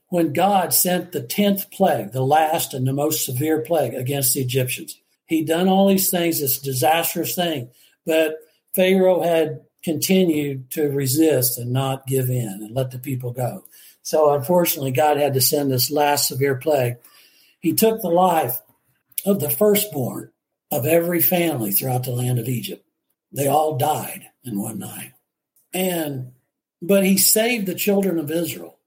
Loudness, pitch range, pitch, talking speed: -20 LUFS, 135-175 Hz, 155 Hz, 160 wpm